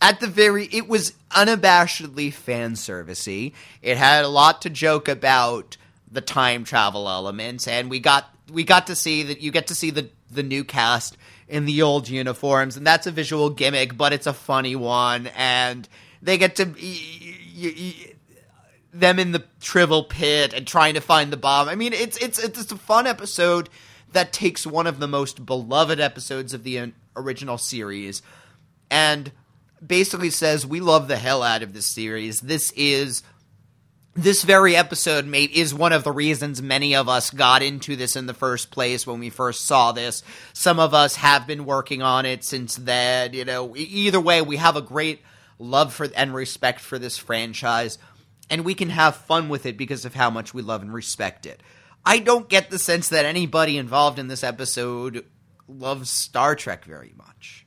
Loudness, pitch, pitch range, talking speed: -20 LUFS, 140 Hz, 125-160 Hz, 190 wpm